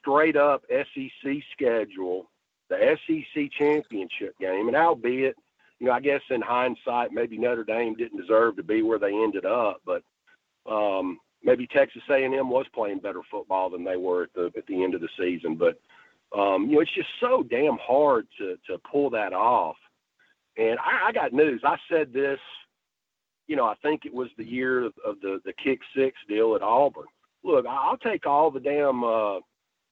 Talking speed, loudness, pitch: 185 wpm, -25 LUFS, 135 Hz